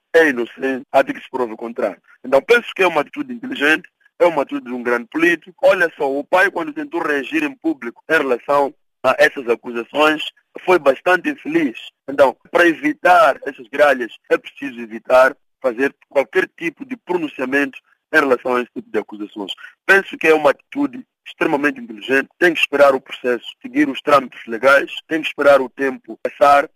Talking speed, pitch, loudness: 185 wpm, 145 Hz, -17 LUFS